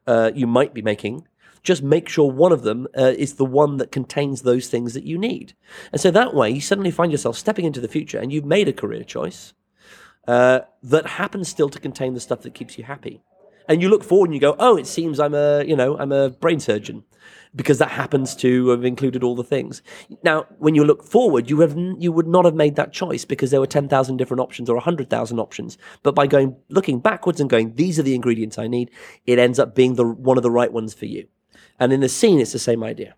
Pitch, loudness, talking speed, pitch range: 140 Hz, -19 LUFS, 250 wpm, 125-160 Hz